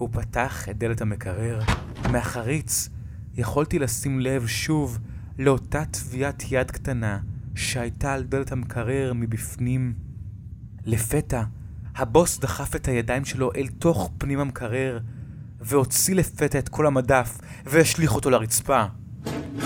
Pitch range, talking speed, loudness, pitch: 115-135 Hz, 115 wpm, -25 LUFS, 125 Hz